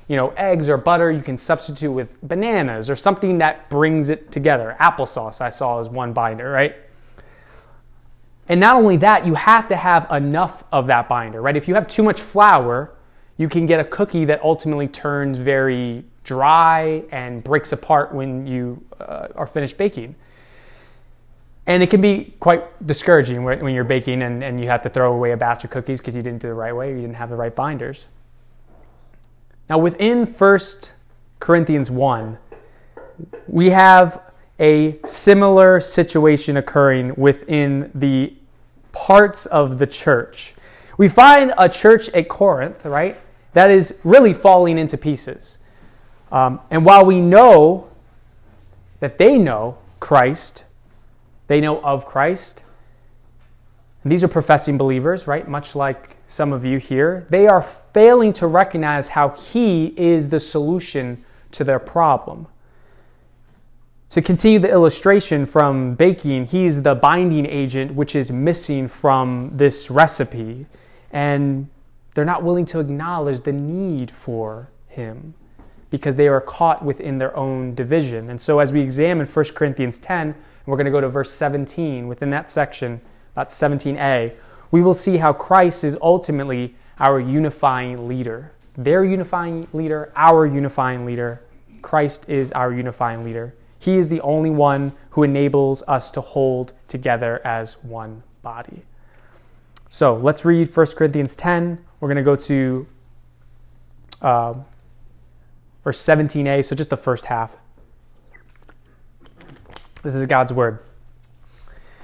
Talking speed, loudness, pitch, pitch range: 150 wpm, -16 LUFS, 140 Hz, 125-165 Hz